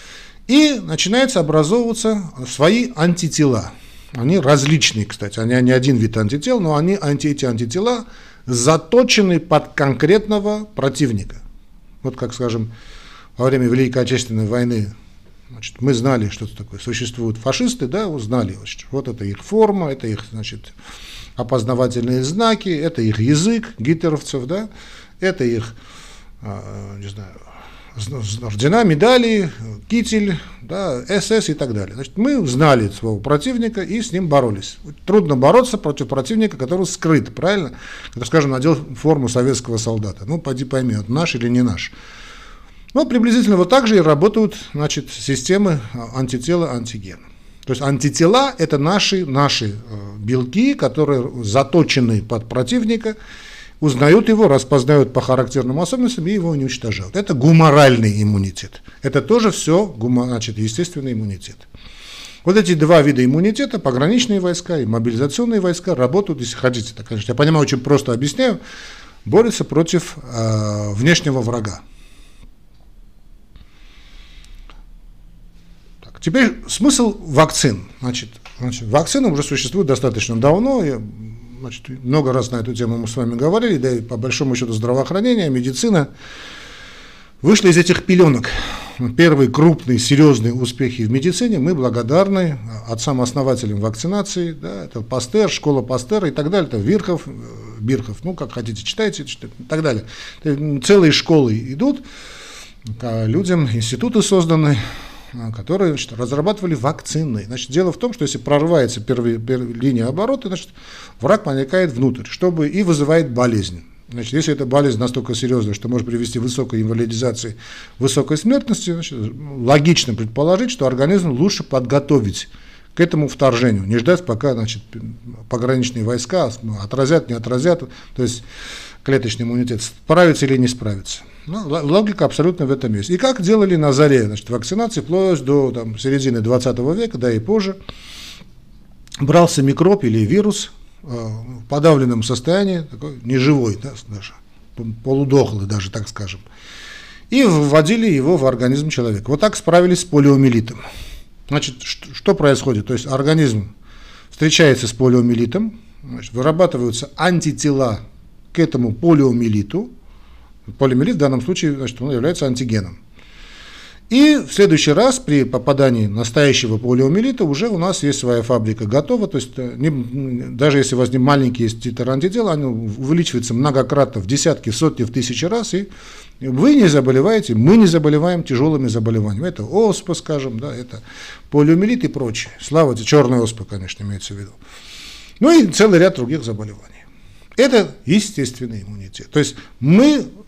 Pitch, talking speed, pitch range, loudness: 135 Hz, 135 wpm, 120-170 Hz, -16 LUFS